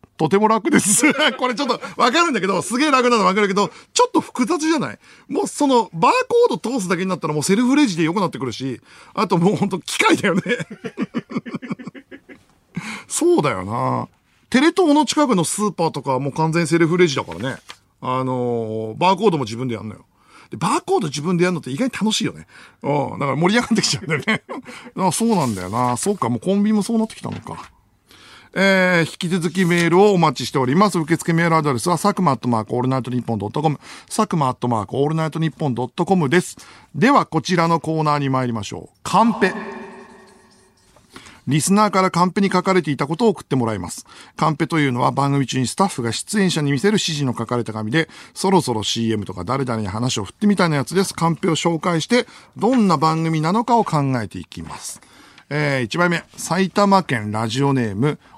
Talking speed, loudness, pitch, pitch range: 430 characters per minute, -19 LUFS, 170 Hz, 135-210 Hz